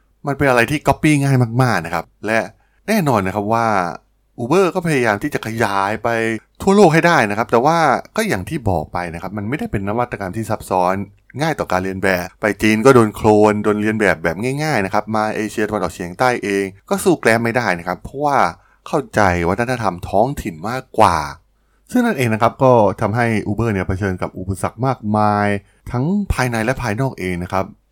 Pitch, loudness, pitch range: 110 Hz, -17 LUFS, 100-125 Hz